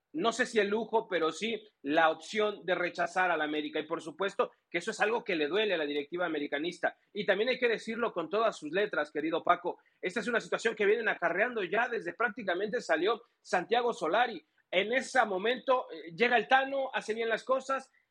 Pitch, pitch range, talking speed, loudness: 215 Hz, 175-245 Hz, 205 wpm, -31 LUFS